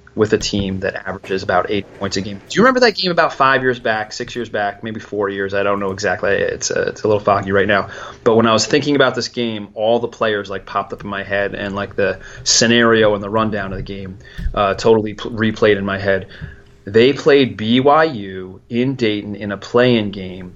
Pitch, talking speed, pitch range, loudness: 105 Hz, 235 wpm, 100-120 Hz, -17 LUFS